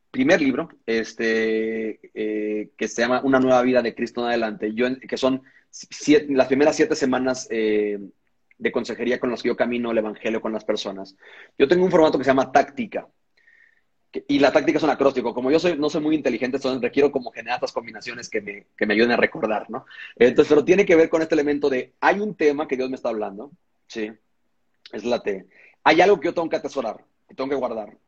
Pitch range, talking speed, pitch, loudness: 110-155 Hz, 220 wpm, 130 Hz, -21 LUFS